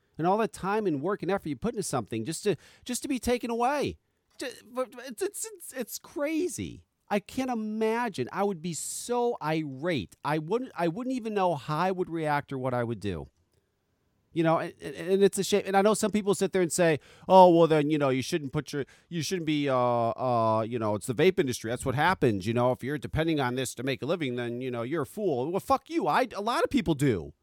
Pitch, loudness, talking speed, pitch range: 165 Hz, -28 LUFS, 245 wpm, 130-210 Hz